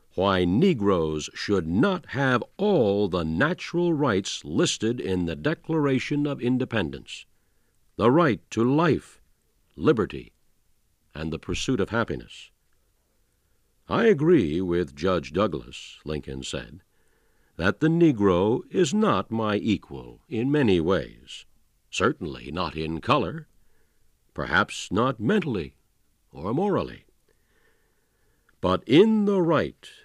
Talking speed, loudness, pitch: 110 wpm, -24 LUFS, 110 Hz